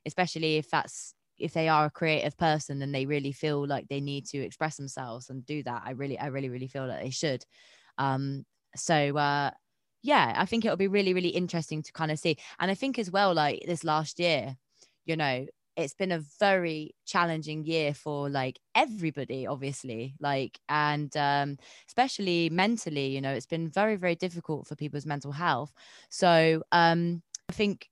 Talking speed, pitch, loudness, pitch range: 190 wpm, 150 Hz, -29 LUFS, 140-170 Hz